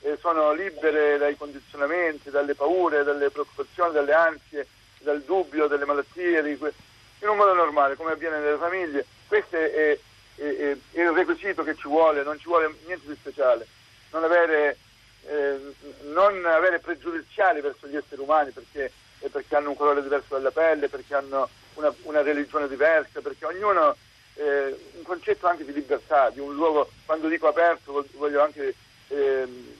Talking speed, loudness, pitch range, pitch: 160 wpm, -24 LUFS, 145-170 Hz, 150 Hz